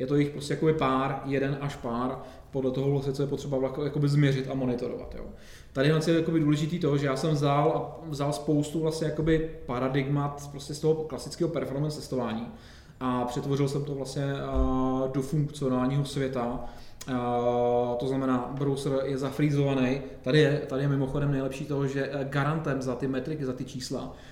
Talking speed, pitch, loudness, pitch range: 165 wpm, 140 Hz, -28 LUFS, 130-145 Hz